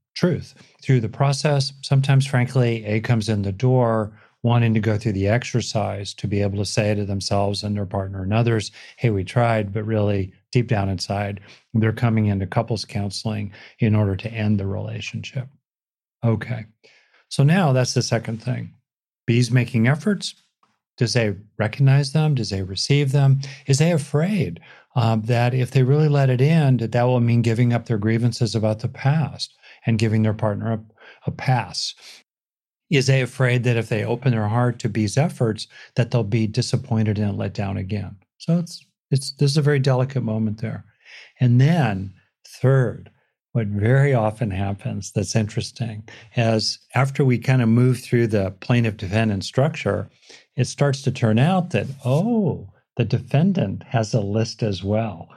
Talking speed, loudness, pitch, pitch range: 170 wpm, -21 LUFS, 115 Hz, 110-130 Hz